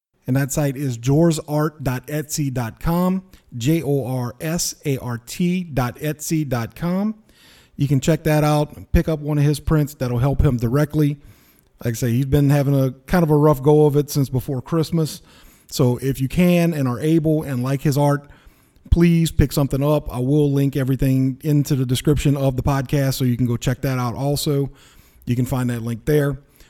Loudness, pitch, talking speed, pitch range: -20 LUFS, 145 Hz, 185 wpm, 130-155 Hz